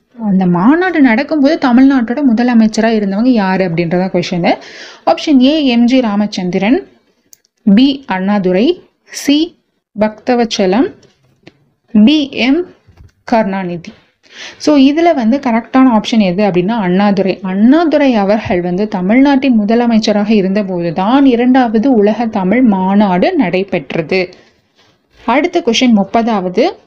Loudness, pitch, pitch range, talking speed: -11 LUFS, 225 Hz, 195-265 Hz, 95 wpm